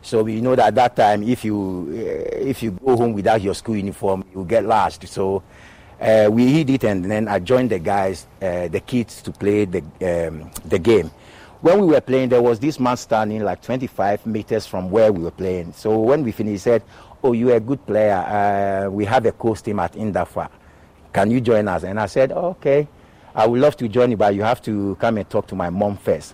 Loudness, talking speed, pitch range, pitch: -19 LUFS, 230 wpm, 100-120 Hz, 110 Hz